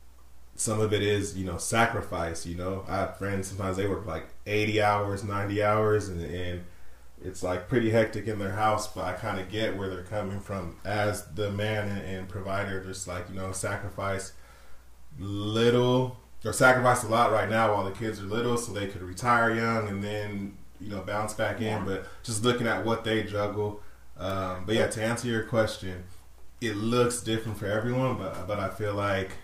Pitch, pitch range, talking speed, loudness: 100 Hz, 95-110 Hz, 200 wpm, -29 LUFS